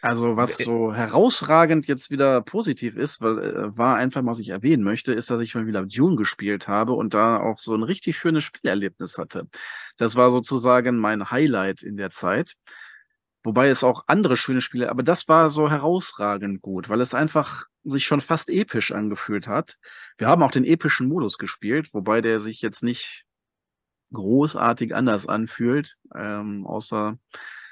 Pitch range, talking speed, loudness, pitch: 110-145 Hz, 170 wpm, -22 LUFS, 120 Hz